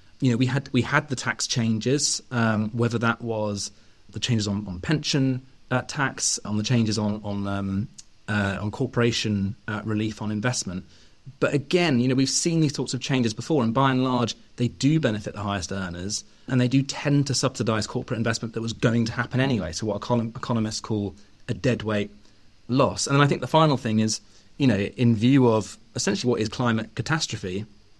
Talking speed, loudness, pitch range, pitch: 200 wpm, -24 LUFS, 105-130 Hz, 115 Hz